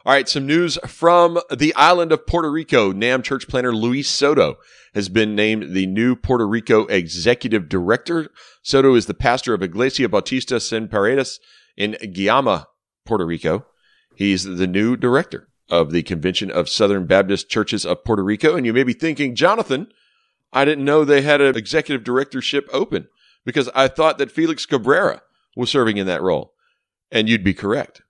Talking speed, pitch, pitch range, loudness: 175 wpm, 125 Hz, 105-145 Hz, -18 LUFS